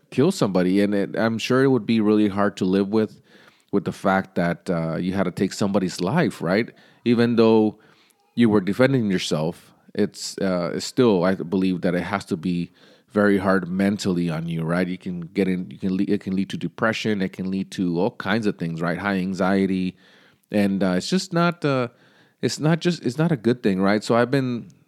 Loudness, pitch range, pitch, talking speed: -22 LUFS, 95-115 Hz, 100 Hz, 215 wpm